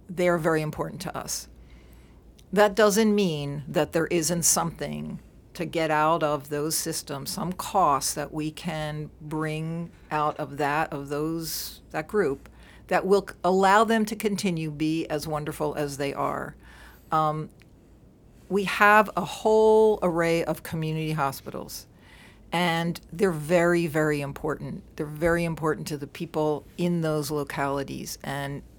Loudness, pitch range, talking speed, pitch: -26 LUFS, 150-175 Hz, 140 wpm, 155 Hz